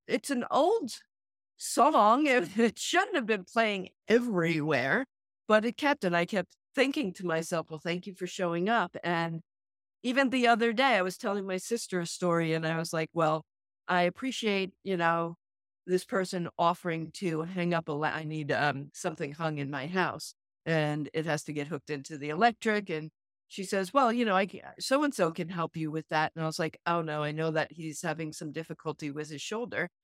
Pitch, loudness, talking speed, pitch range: 175 Hz, -30 LUFS, 210 wpm, 160-210 Hz